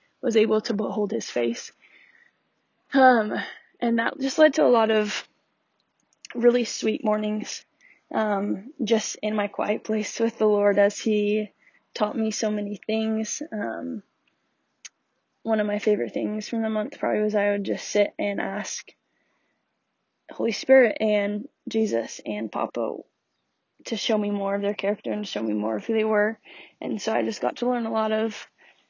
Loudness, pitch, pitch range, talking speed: -25 LUFS, 215 Hz, 205-230 Hz, 170 wpm